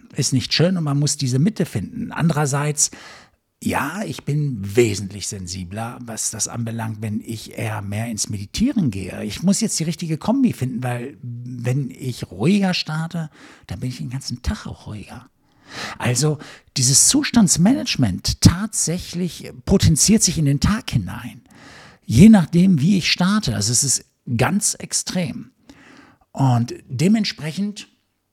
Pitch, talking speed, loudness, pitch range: 140 Hz, 140 wpm, -19 LUFS, 115-180 Hz